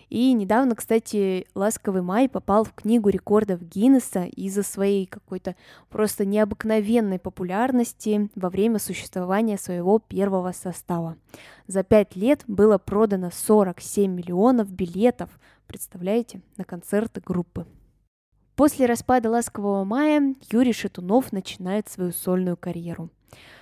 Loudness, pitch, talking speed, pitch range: -23 LUFS, 205 Hz, 110 wpm, 185-225 Hz